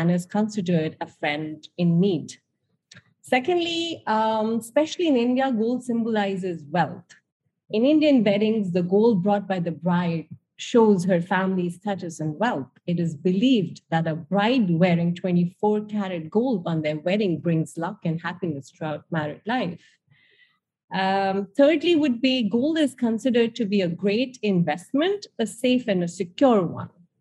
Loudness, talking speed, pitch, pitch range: -23 LUFS, 150 wpm, 195 Hz, 170-235 Hz